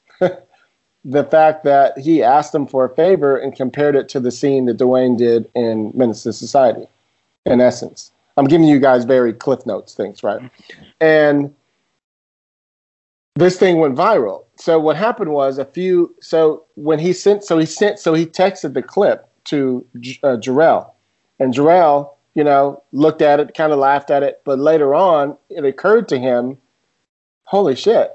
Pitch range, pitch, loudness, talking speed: 130-160 Hz, 145 Hz, -15 LUFS, 165 wpm